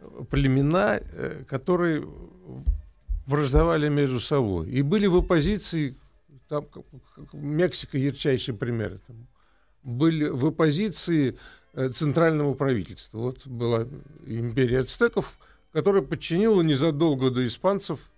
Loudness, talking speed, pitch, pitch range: -25 LUFS, 95 wpm, 145 Hz, 125-165 Hz